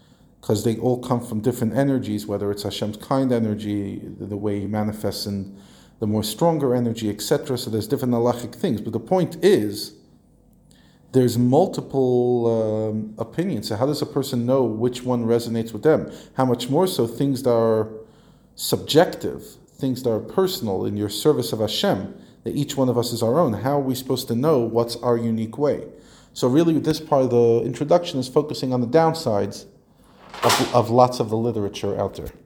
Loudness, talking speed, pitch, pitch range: -22 LUFS, 185 wpm, 120 Hz, 110-130 Hz